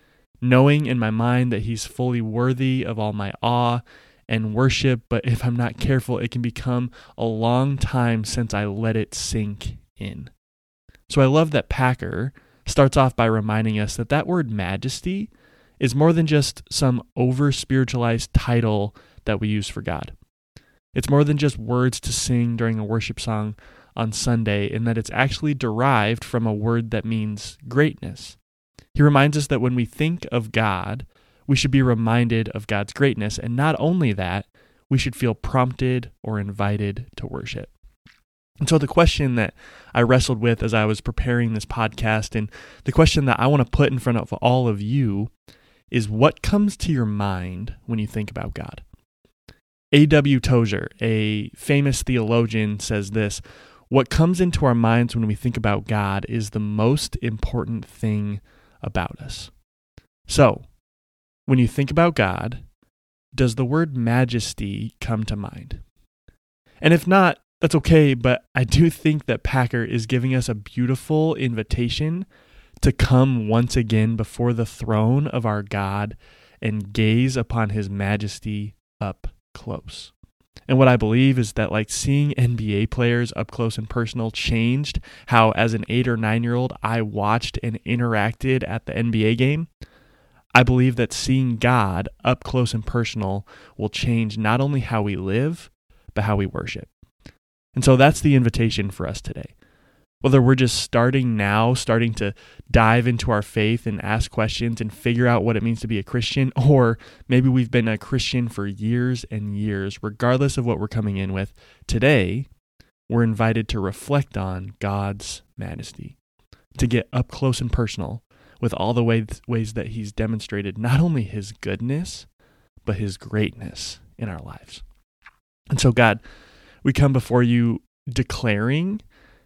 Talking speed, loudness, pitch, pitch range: 165 wpm, -21 LUFS, 115 Hz, 110-130 Hz